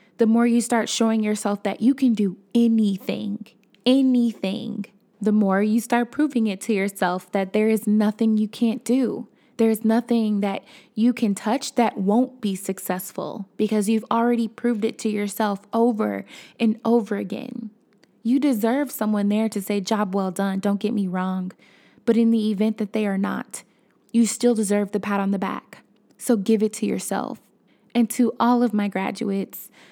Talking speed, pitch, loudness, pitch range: 180 wpm, 215 Hz, -22 LUFS, 205-235 Hz